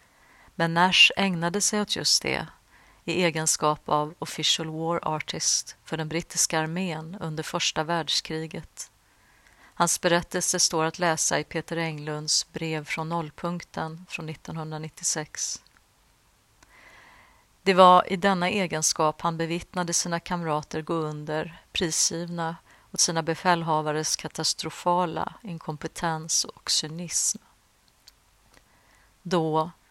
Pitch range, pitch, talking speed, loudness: 155-175 Hz, 165 Hz, 105 wpm, -25 LUFS